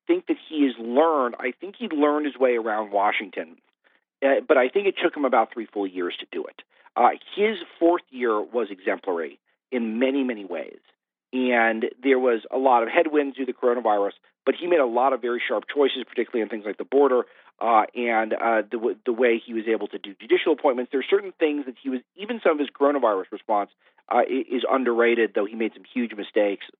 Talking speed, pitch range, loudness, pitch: 220 wpm, 115-150 Hz, -24 LUFS, 130 Hz